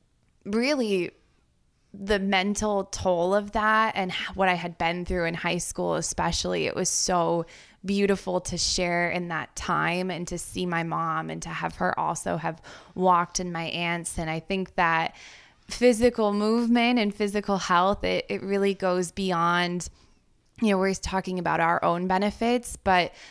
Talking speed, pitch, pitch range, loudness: 160 wpm, 185 Hz, 170-200 Hz, -26 LUFS